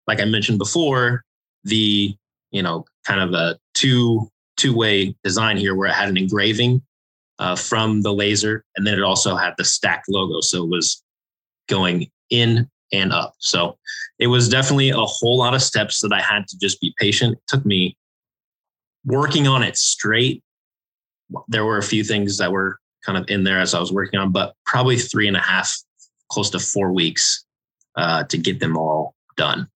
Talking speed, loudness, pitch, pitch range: 190 wpm, -19 LUFS, 105 Hz, 100-120 Hz